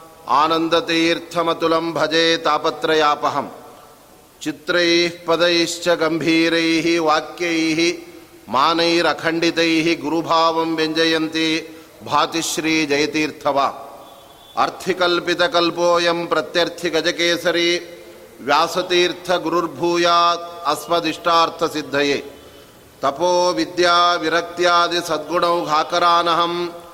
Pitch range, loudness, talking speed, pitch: 160-170 Hz, -18 LUFS, 40 wpm, 165 Hz